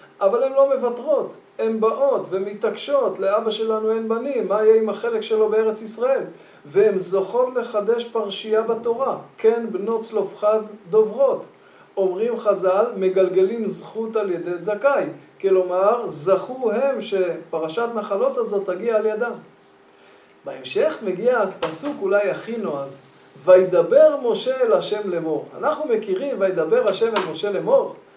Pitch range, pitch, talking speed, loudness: 195-250 Hz, 220 Hz, 130 wpm, -21 LUFS